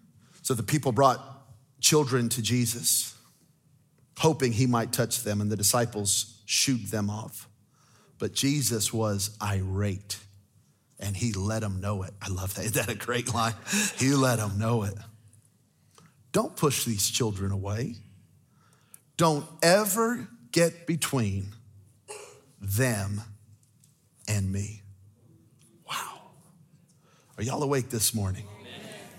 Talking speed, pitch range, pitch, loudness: 120 wpm, 105-135 Hz, 115 Hz, -27 LUFS